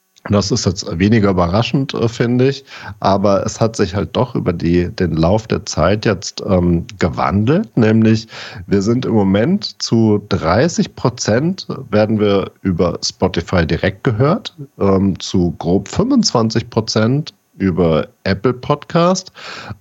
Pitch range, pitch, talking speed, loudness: 95-125 Hz, 110 Hz, 135 wpm, -16 LUFS